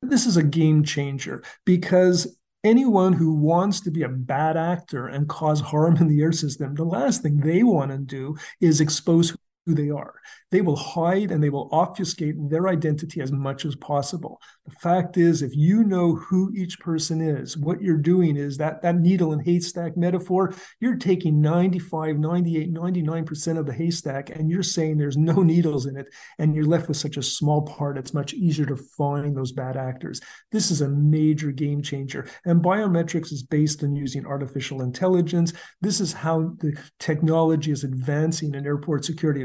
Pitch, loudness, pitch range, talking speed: 160 Hz, -23 LUFS, 145-175 Hz, 185 wpm